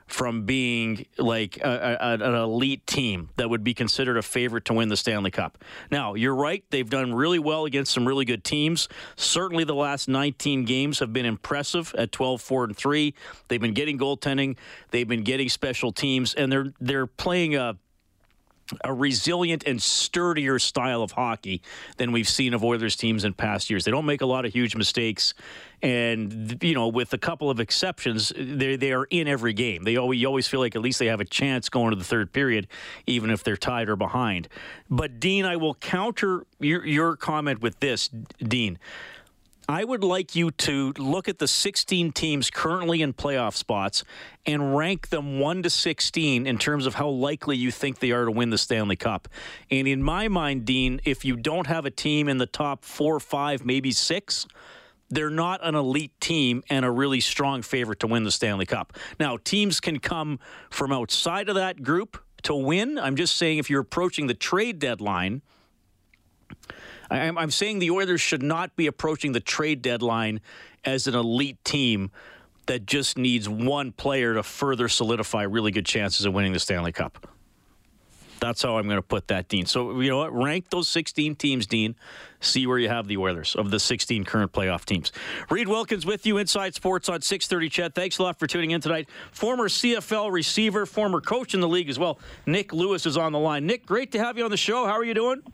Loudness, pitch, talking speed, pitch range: -25 LUFS, 135 Hz, 200 wpm, 115-160 Hz